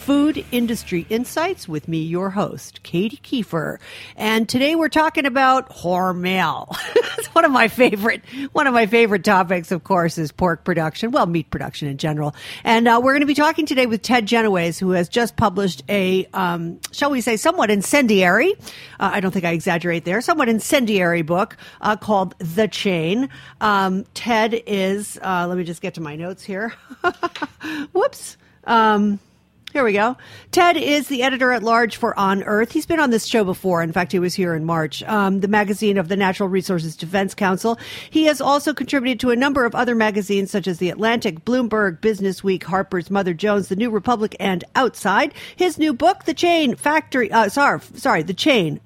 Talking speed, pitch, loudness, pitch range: 190 wpm, 210 Hz, -19 LUFS, 185-255 Hz